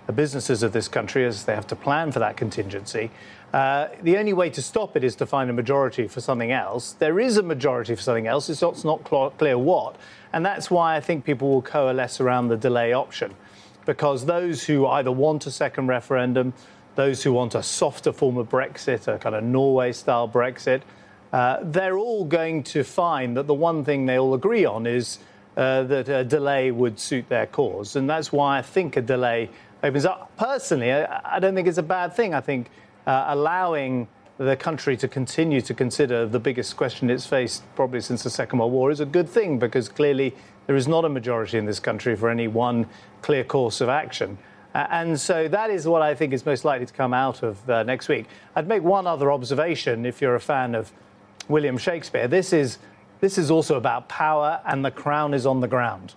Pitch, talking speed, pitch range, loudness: 135 Hz, 215 wpm, 120-155 Hz, -23 LUFS